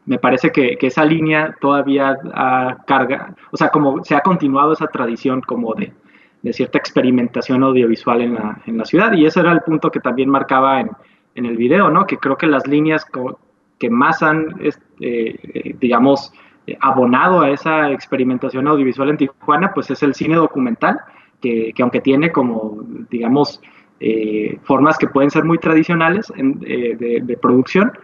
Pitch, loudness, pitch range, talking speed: 140 Hz, -15 LUFS, 125-155 Hz, 175 wpm